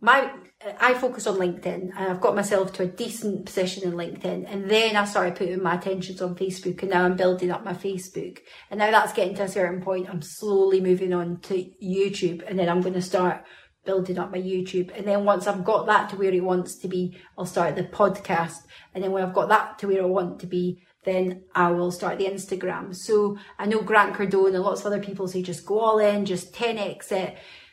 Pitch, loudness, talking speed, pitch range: 190 Hz, -25 LUFS, 230 wpm, 180-200 Hz